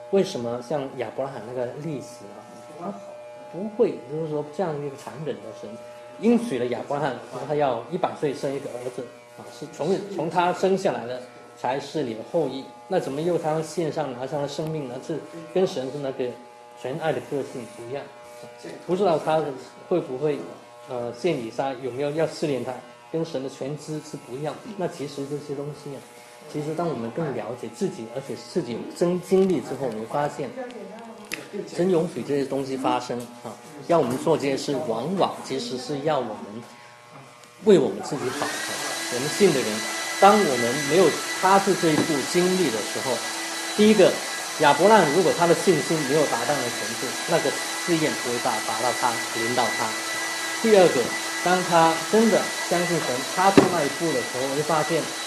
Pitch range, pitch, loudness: 125-170 Hz, 145 Hz, -24 LUFS